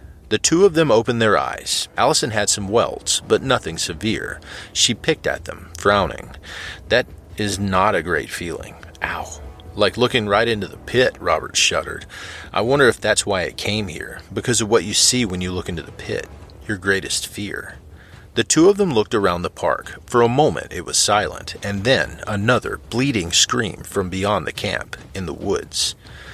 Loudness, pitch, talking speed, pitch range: -19 LUFS, 100 Hz, 185 wpm, 90-115 Hz